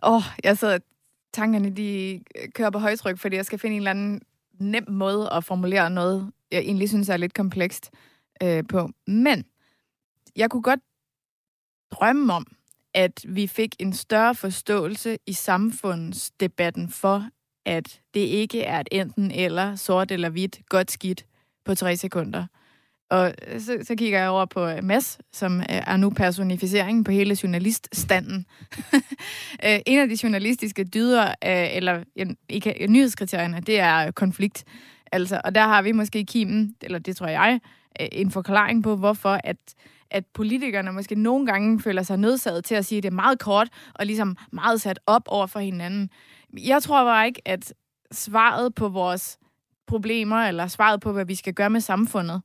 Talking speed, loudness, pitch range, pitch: 165 wpm, -23 LUFS, 185-220 Hz, 200 Hz